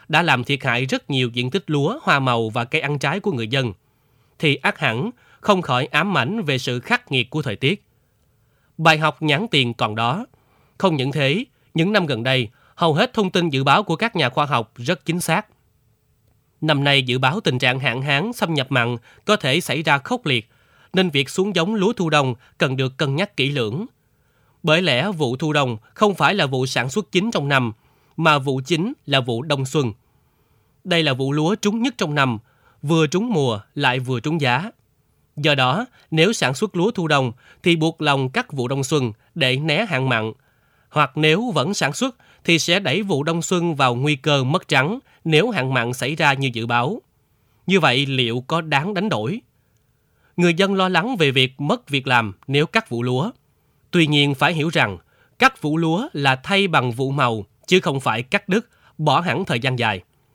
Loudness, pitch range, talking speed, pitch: -20 LUFS, 130-170 Hz, 210 wpm, 145 Hz